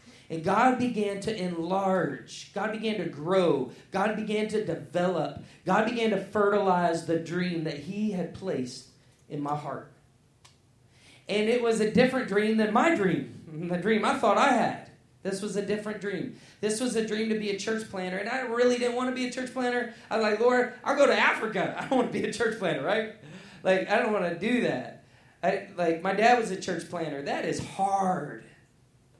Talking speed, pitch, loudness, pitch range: 205 wpm, 195 Hz, -27 LUFS, 165-220 Hz